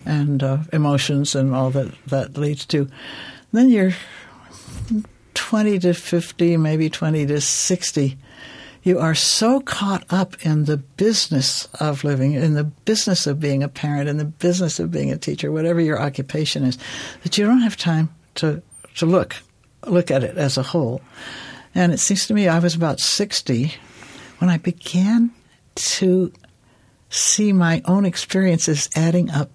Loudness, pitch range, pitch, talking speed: -19 LUFS, 140-180 Hz, 160 Hz, 160 wpm